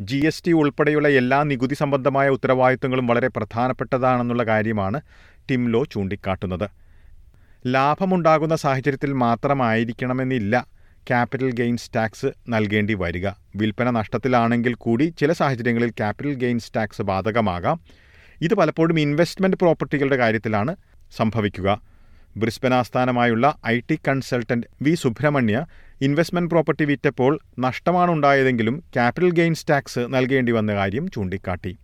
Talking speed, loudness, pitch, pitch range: 105 wpm, -21 LUFS, 125 Hz, 110-140 Hz